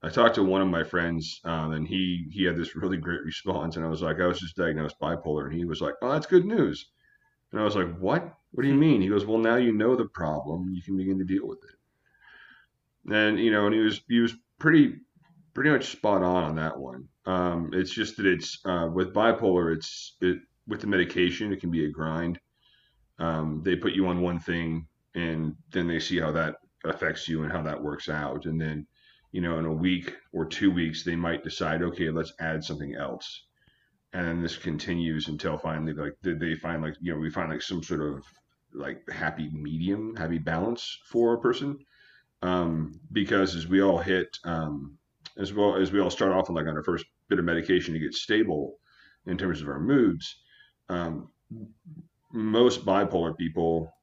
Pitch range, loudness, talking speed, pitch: 80-95 Hz, -27 LUFS, 210 wpm, 85 Hz